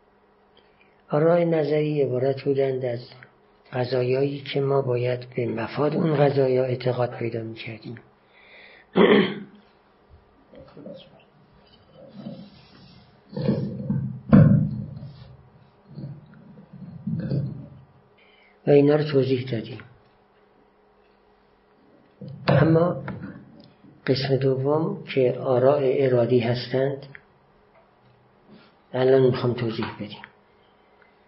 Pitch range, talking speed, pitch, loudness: 125-150 Hz, 60 wpm, 135 Hz, -23 LUFS